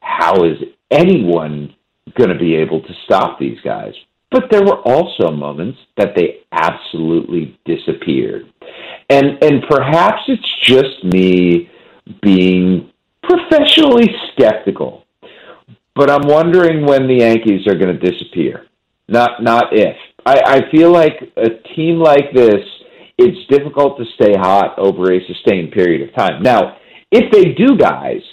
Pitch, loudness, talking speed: 140 Hz, -12 LUFS, 140 wpm